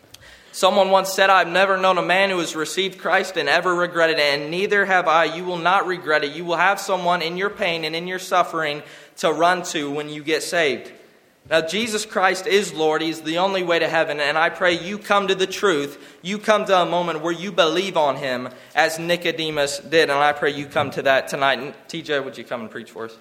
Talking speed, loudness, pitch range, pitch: 240 wpm, -20 LUFS, 155-190 Hz, 170 Hz